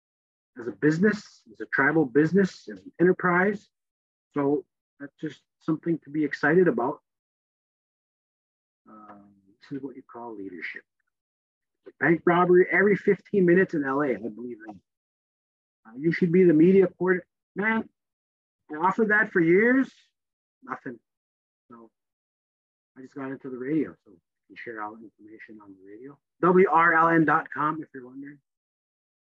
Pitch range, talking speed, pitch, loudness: 120-180 Hz, 145 wpm, 150 Hz, -23 LUFS